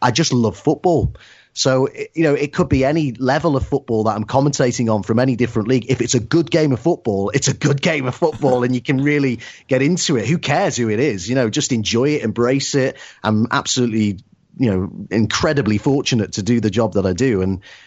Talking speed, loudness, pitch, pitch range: 230 wpm, -18 LUFS, 130 Hz, 115-145 Hz